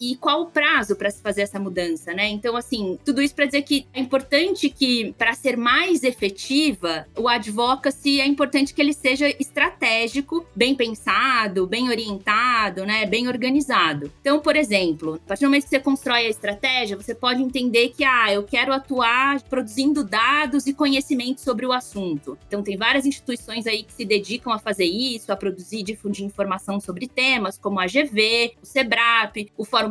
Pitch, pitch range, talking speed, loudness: 245 Hz, 210-275 Hz, 185 wpm, -21 LUFS